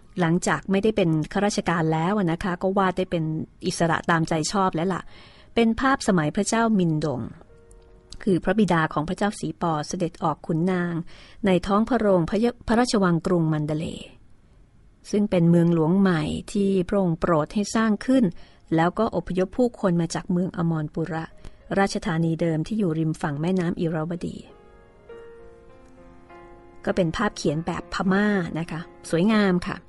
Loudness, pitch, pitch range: -24 LUFS, 180 Hz, 160-200 Hz